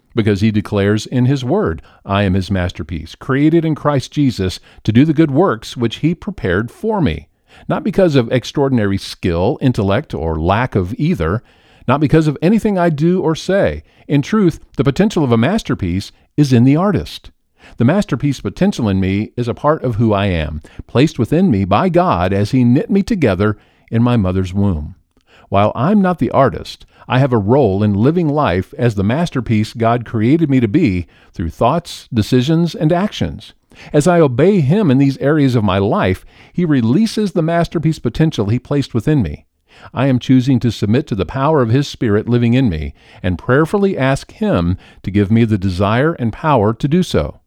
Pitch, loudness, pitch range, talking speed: 125 Hz, -15 LUFS, 100-155 Hz, 190 wpm